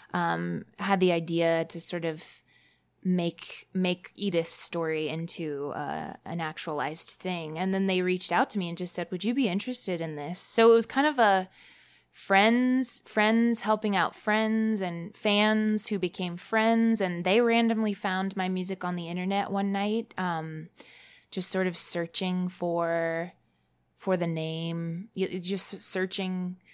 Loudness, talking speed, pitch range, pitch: -27 LUFS, 155 wpm, 170-210 Hz, 185 Hz